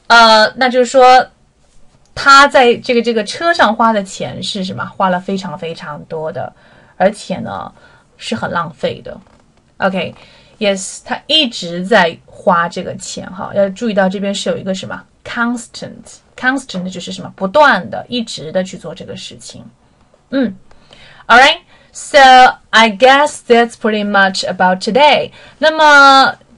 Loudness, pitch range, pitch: -11 LUFS, 190-255 Hz, 220 Hz